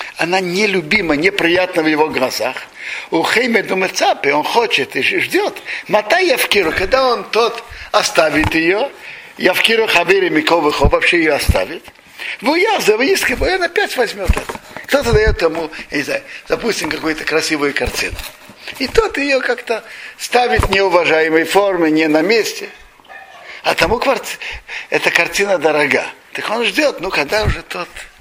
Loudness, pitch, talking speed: -15 LUFS, 200 Hz, 145 wpm